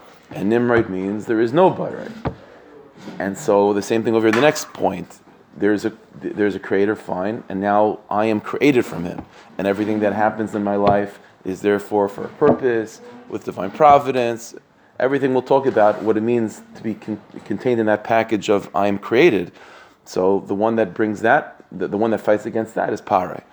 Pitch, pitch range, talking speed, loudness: 105 Hz, 100-115 Hz, 195 wpm, -19 LUFS